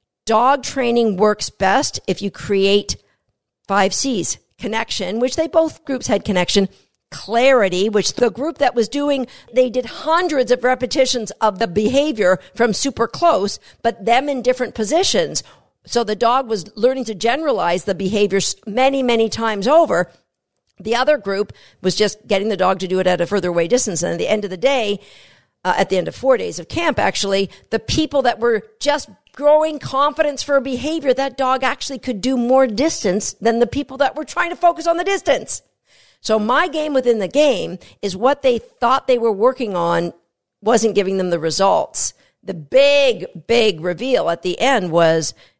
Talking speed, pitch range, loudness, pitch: 185 wpm, 195-270 Hz, -18 LUFS, 235 Hz